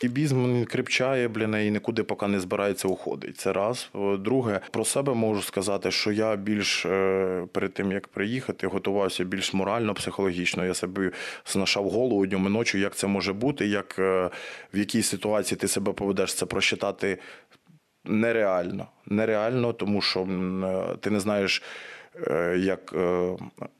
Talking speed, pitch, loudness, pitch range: 140 wpm, 100 Hz, -26 LUFS, 95-110 Hz